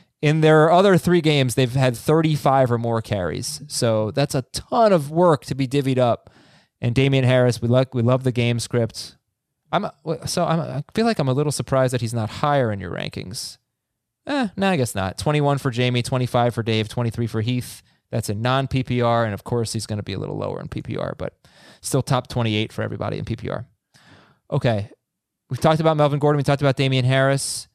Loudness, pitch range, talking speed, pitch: -21 LUFS, 115-145 Hz, 215 wpm, 130 Hz